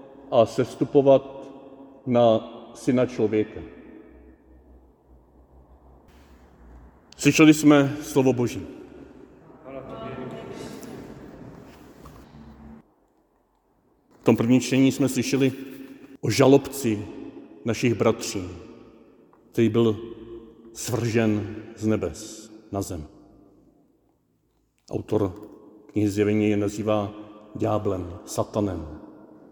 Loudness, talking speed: -23 LUFS, 65 wpm